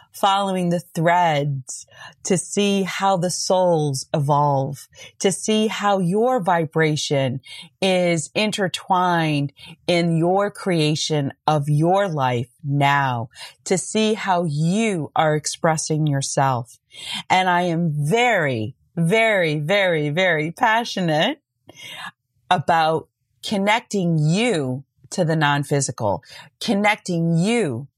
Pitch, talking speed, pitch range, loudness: 165 Hz, 100 wpm, 145-190 Hz, -20 LUFS